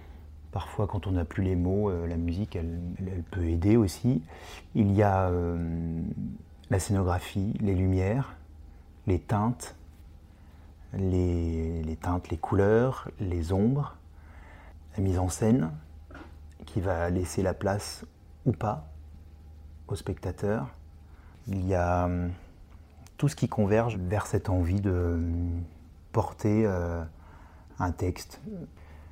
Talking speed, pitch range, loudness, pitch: 125 wpm, 80-95 Hz, -29 LUFS, 85 Hz